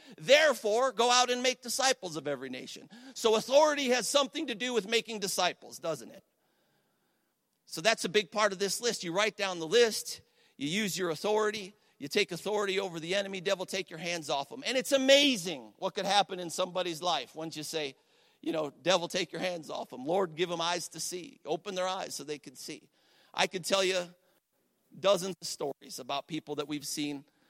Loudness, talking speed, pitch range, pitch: -30 LUFS, 205 wpm, 165-225 Hz, 190 Hz